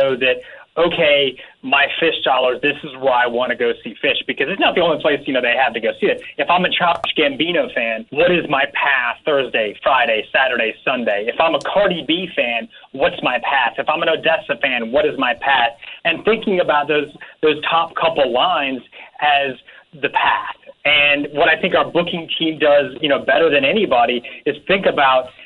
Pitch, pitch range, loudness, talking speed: 150 Hz, 130-175 Hz, -17 LUFS, 205 wpm